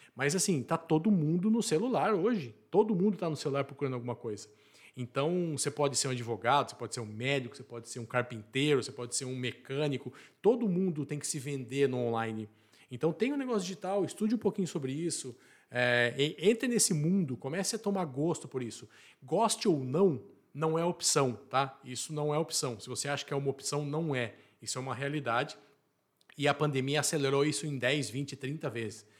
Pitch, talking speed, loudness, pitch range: 140 Hz, 205 wpm, -32 LUFS, 125-165 Hz